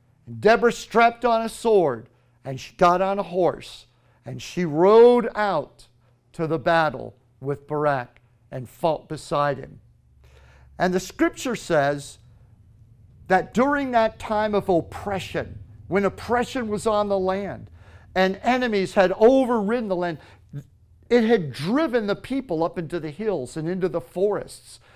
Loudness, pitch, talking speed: -22 LUFS, 170 Hz, 140 wpm